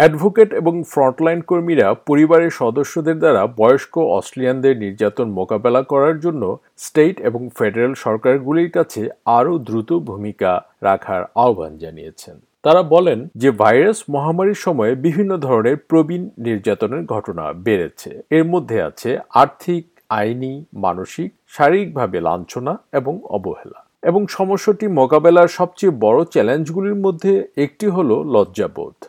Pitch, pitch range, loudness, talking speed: 160 Hz, 130-180 Hz, -17 LUFS, 115 wpm